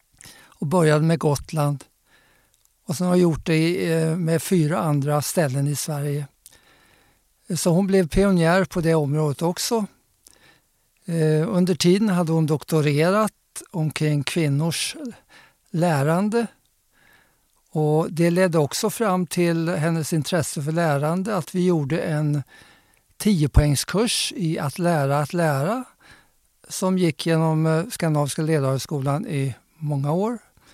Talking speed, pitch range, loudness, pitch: 115 wpm, 150-180 Hz, -22 LUFS, 165 Hz